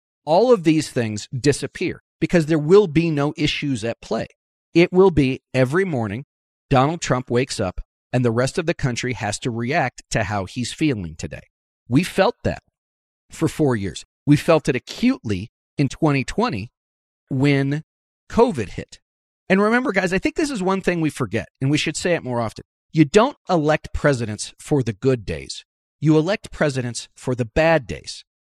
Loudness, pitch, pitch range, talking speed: -20 LUFS, 135 Hz, 115-160 Hz, 175 wpm